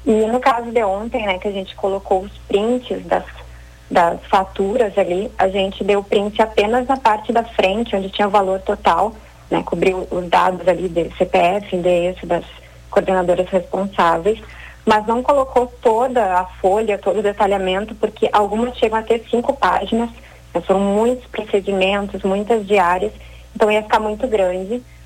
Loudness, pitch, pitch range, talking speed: -18 LUFS, 200 Hz, 185-220 Hz, 160 wpm